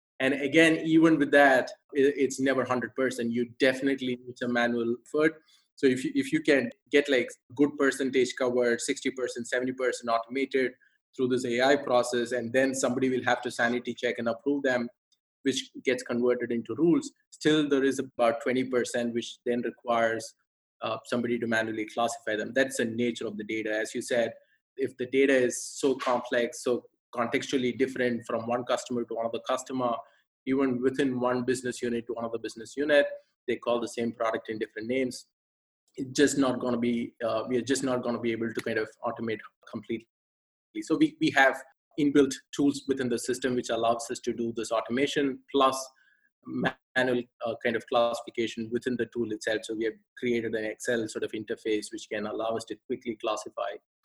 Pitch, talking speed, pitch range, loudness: 125 Hz, 185 wpm, 115-135 Hz, -28 LUFS